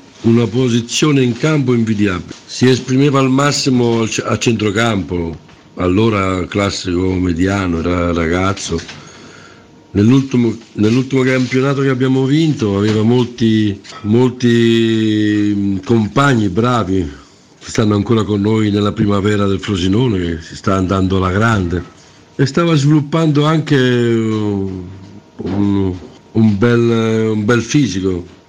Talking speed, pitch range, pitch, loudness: 110 wpm, 95-125 Hz, 110 Hz, -14 LUFS